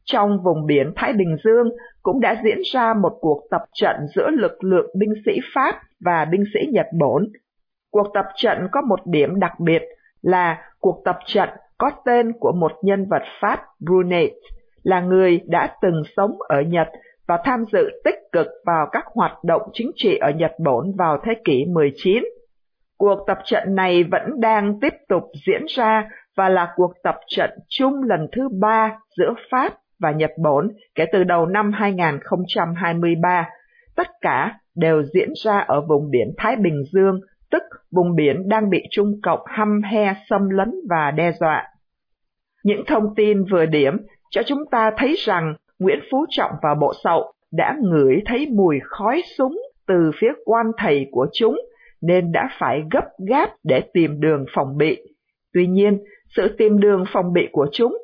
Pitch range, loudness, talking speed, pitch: 175-230 Hz, -19 LUFS, 175 wpm, 200 Hz